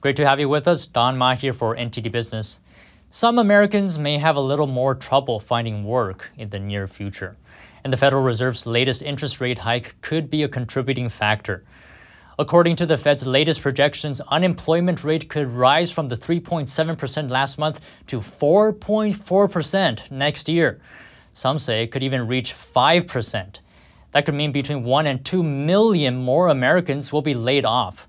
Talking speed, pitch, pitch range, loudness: 170 wpm, 135 Hz, 120-155 Hz, -20 LUFS